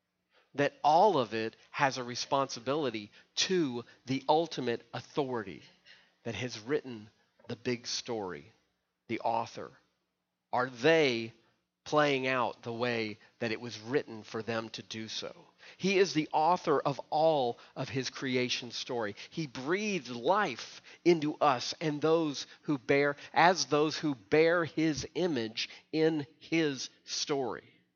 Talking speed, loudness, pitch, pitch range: 135 wpm, -31 LUFS, 135 Hz, 120-155 Hz